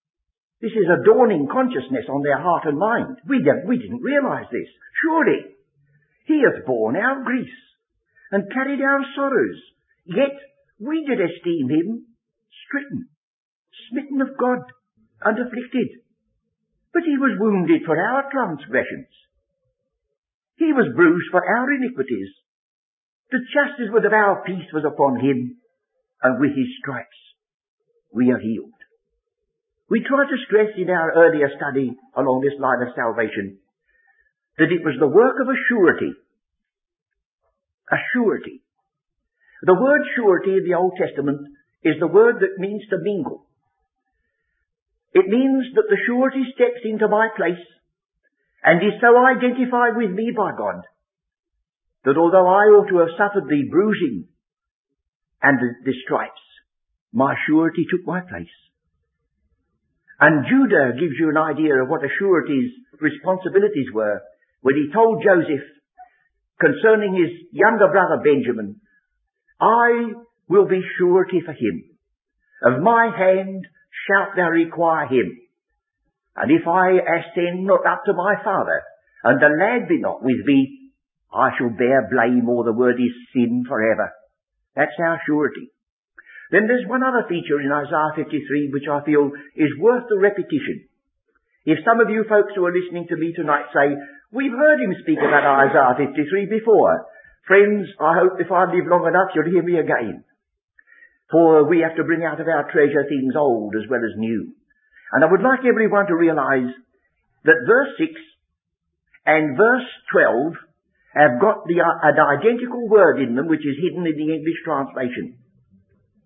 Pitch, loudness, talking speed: 190 Hz, -19 LUFS, 150 wpm